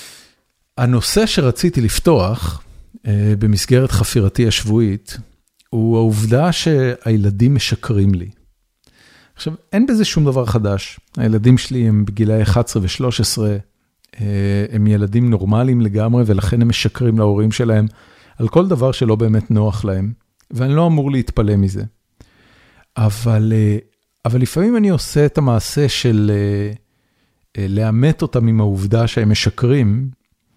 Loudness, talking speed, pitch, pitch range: -16 LUFS, 125 wpm, 110 Hz, 105-125 Hz